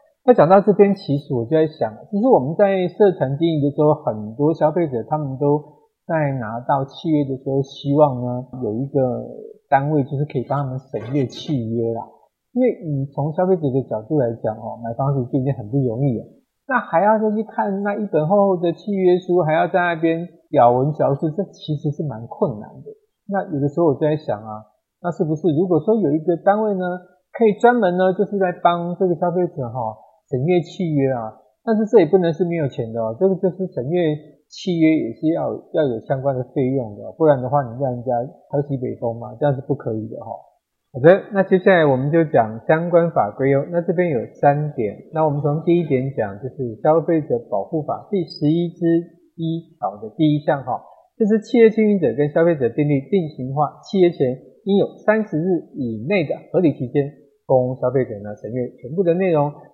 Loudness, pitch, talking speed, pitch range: -19 LUFS, 150 Hz, 305 characters per minute, 135-180 Hz